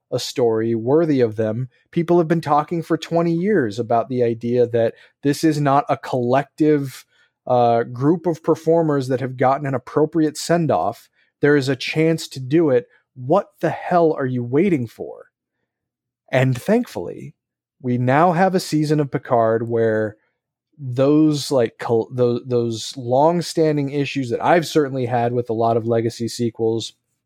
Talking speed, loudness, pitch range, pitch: 160 wpm, -19 LUFS, 120-160 Hz, 135 Hz